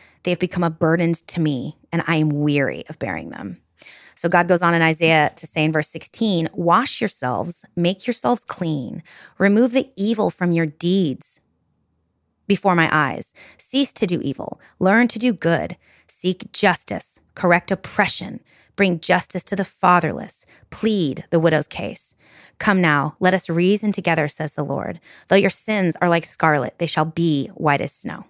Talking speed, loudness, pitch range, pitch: 170 wpm, -20 LUFS, 155-195 Hz, 170 Hz